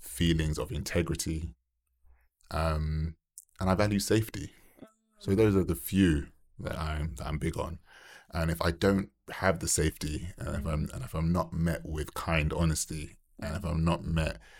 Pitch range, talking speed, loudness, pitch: 80-95 Hz, 175 wpm, -31 LUFS, 80 Hz